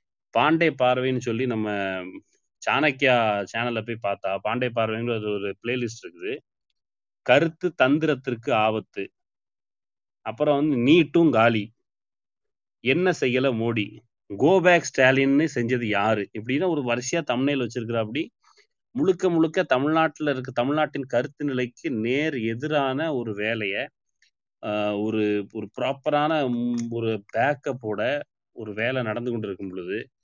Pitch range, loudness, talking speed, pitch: 110-145 Hz, -24 LUFS, 105 wpm, 120 Hz